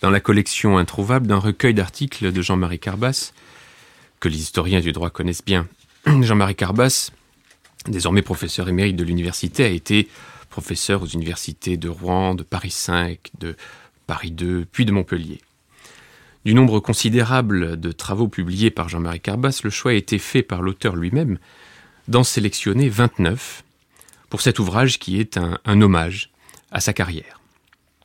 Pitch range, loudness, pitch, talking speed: 90-115 Hz, -20 LUFS, 100 Hz, 150 wpm